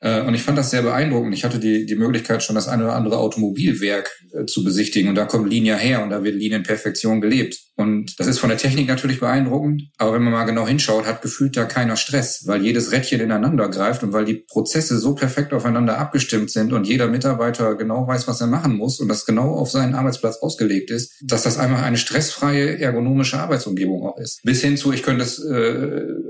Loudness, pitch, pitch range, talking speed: -19 LUFS, 120 Hz, 110-135 Hz, 215 wpm